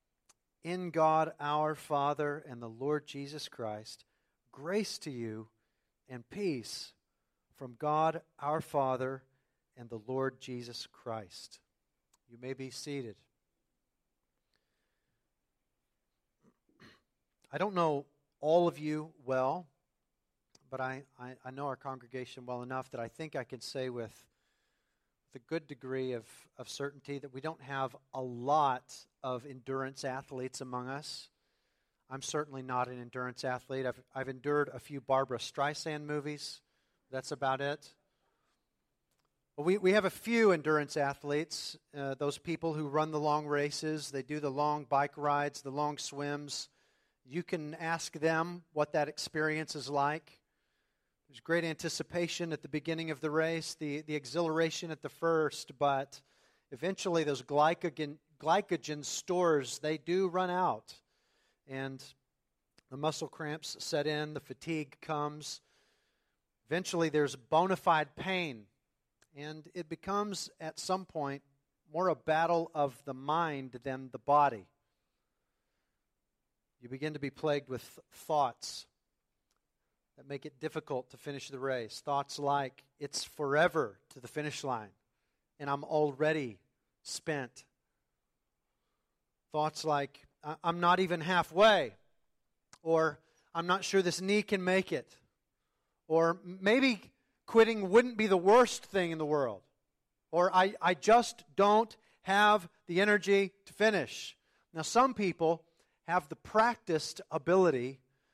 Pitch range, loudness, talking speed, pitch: 135-165 Hz, -33 LUFS, 135 wpm, 150 Hz